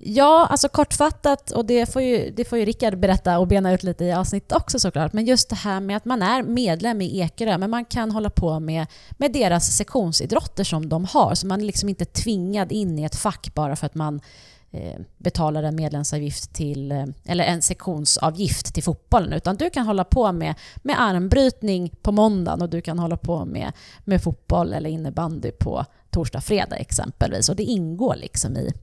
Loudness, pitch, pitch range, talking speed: -22 LUFS, 185 Hz, 160-220 Hz, 200 wpm